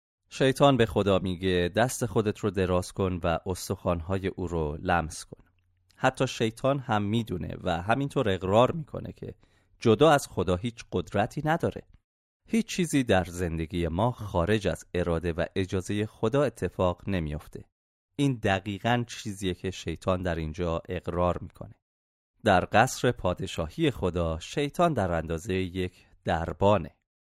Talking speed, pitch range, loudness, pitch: 135 wpm, 90-115 Hz, -28 LUFS, 95 Hz